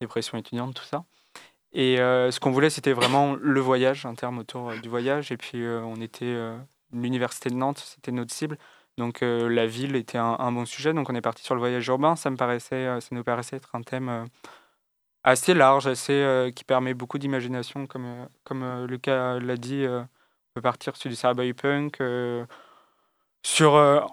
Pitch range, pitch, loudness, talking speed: 120-135 Hz, 125 Hz, -25 LUFS, 210 wpm